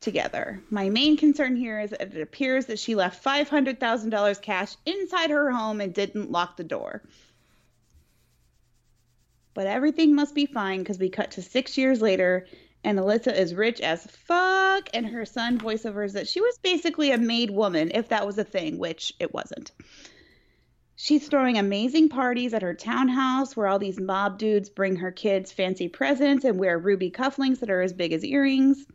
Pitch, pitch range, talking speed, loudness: 220 Hz, 195-275 Hz, 185 wpm, -25 LUFS